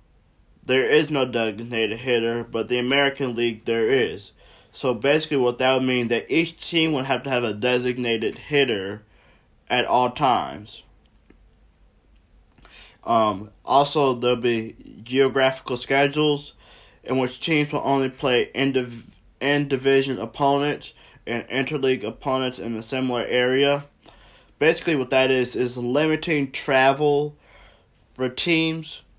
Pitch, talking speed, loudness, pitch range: 130 Hz, 130 wpm, -22 LUFS, 120-140 Hz